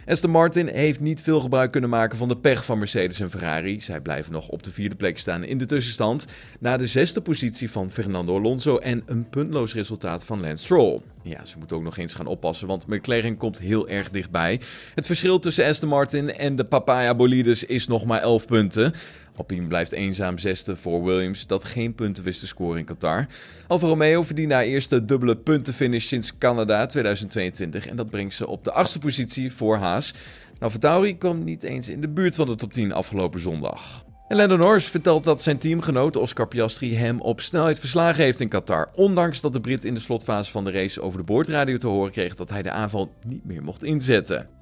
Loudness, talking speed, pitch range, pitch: -23 LUFS, 205 wpm, 100-145 Hz, 115 Hz